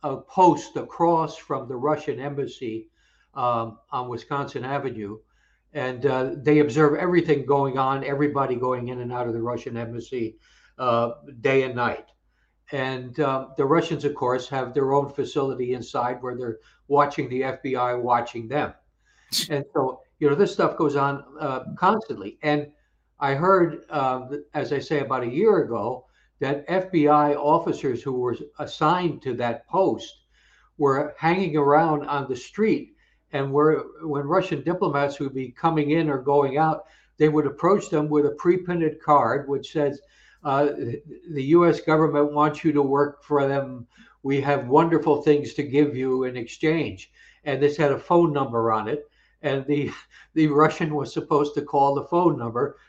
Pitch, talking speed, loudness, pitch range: 145 Hz, 165 wpm, -23 LUFS, 130-155 Hz